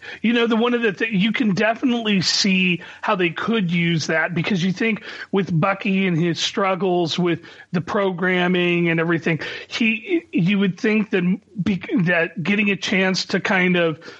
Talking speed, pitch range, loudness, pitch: 175 wpm, 175-210 Hz, -20 LUFS, 190 Hz